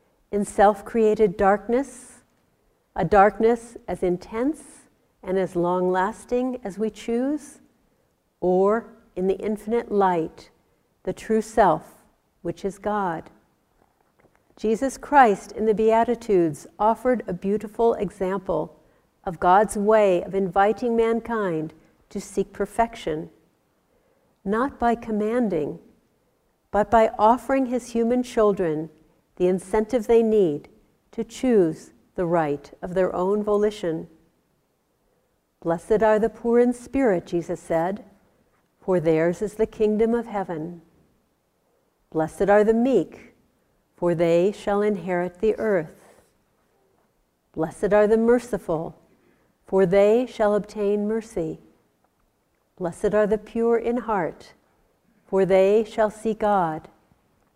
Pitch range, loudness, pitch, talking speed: 185-230 Hz, -23 LUFS, 210 Hz, 115 wpm